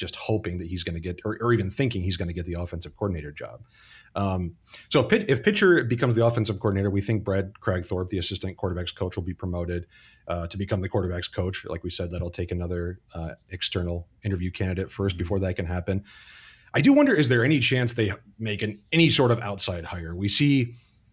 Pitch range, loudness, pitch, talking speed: 90-110 Hz, -26 LUFS, 95 Hz, 220 wpm